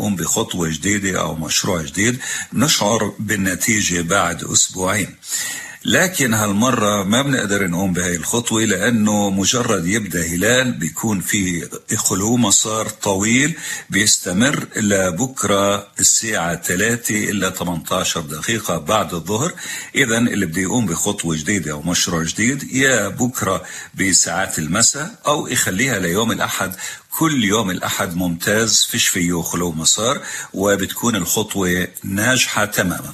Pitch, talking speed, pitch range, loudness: 100 Hz, 120 wpm, 90-110 Hz, -17 LUFS